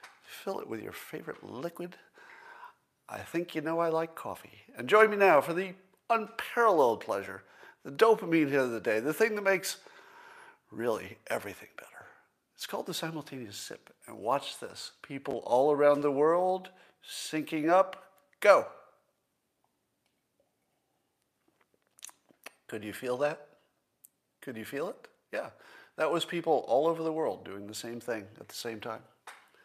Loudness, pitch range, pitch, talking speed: -30 LUFS, 145-200 Hz, 170 Hz, 150 wpm